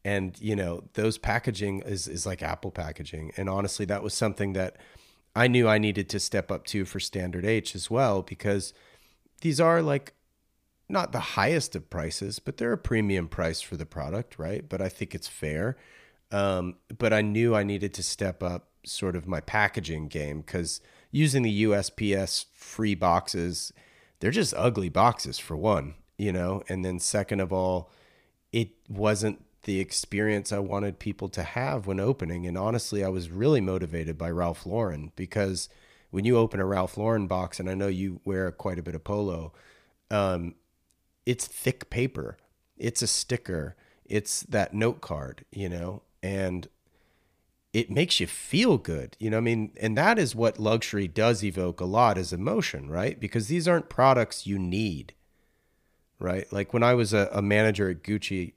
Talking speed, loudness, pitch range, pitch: 180 wpm, -28 LUFS, 90-110 Hz, 100 Hz